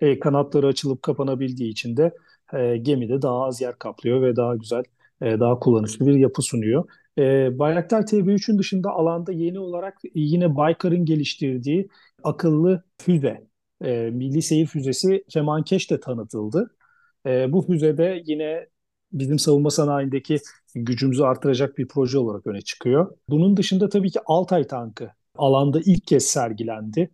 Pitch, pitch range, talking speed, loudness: 145 Hz, 130-170 Hz, 140 wpm, -22 LUFS